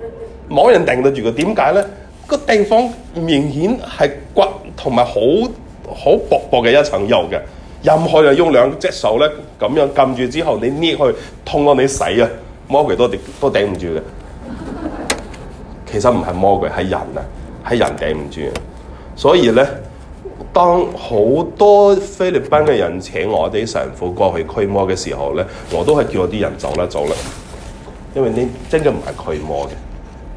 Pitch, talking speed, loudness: 125 Hz, 230 characters per minute, -15 LUFS